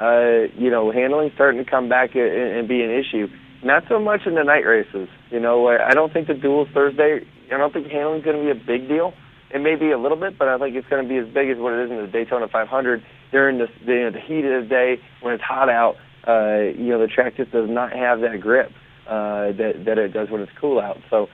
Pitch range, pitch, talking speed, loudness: 120-140 Hz, 130 Hz, 270 wpm, -20 LUFS